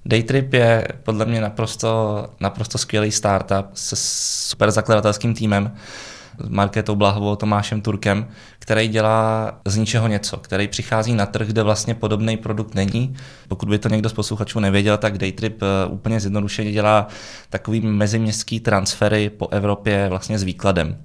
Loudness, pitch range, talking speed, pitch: -20 LUFS, 100-110 Hz, 145 wpm, 105 Hz